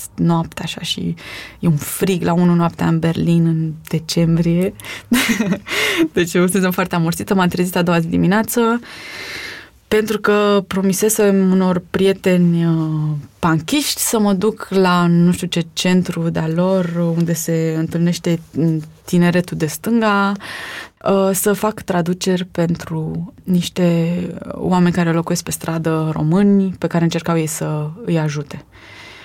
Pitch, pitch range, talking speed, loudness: 175 Hz, 165-195 Hz, 135 wpm, -17 LUFS